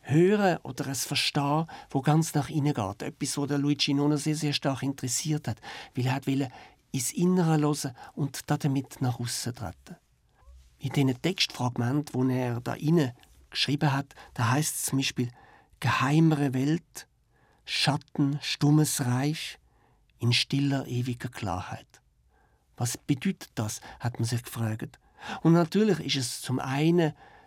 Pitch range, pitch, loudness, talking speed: 125-150 Hz, 140 Hz, -28 LUFS, 145 wpm